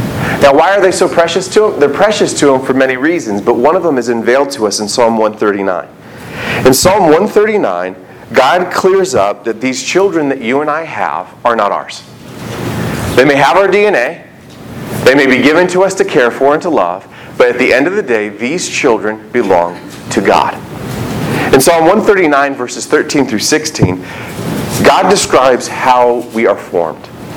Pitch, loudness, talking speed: 130 Hz, -10 LUFS, 185 wpm